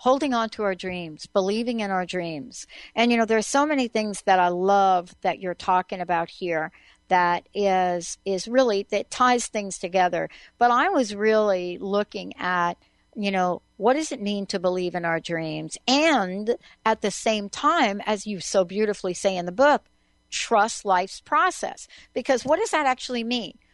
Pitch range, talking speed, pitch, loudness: 180-235 Hz, 180 wpm, 200 Hz, -24 LUFS